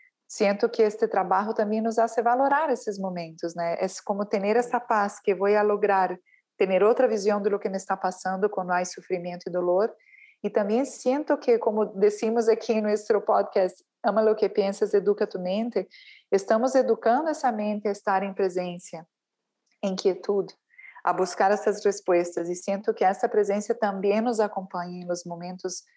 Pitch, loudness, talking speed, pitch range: 205 Hz, -25 LUFS, 170 wpm, 190-225 Hz